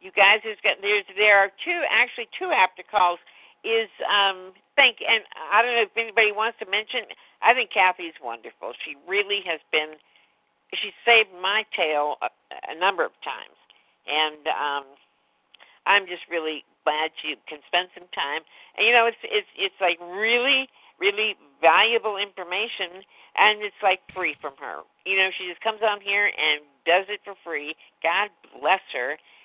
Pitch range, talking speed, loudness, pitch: 175-225 Hz, 165 wpm, -22 LUFS, 200 Hz